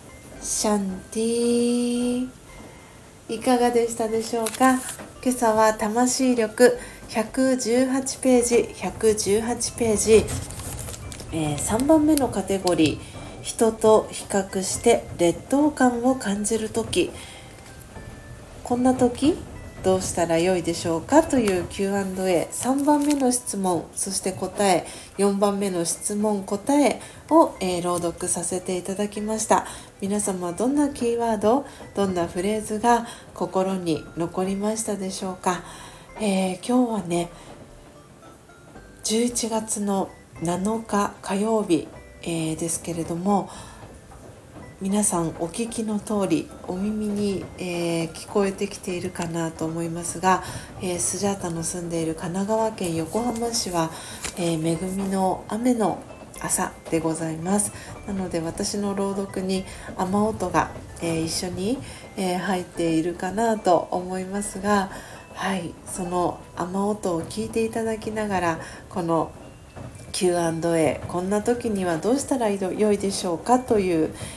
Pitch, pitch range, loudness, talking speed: 195 Hz, 175-225 Hz, -24 LUFS, 235 characters per minute